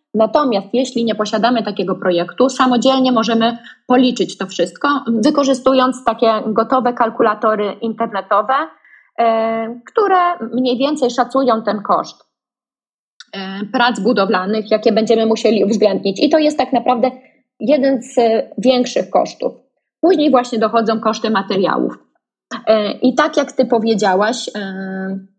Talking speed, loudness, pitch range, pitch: 125 wpm, -15 LUFS, 215-260 Hz, 230 Hz